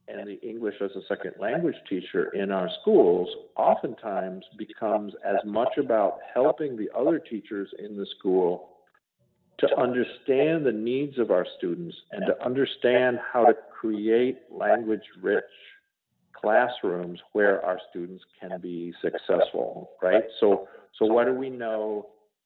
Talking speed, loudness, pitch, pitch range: 140 wpm, -26 LUFS, 110 Hz, 100-135 Hz